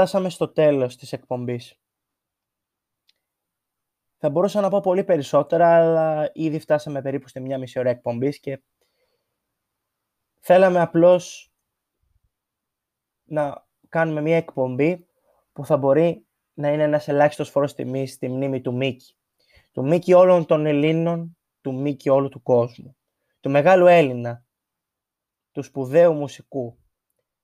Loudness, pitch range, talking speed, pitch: -20 LUFS, 135-170 Hz, 120 wpm, 150 Hz